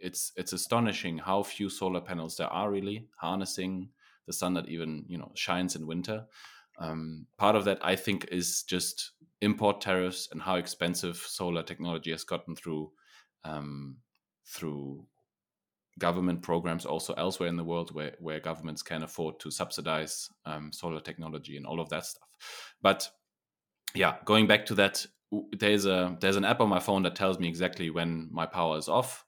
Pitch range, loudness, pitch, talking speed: 80-95 Hz, -31 LUFS, 90 Hz, 175 wpm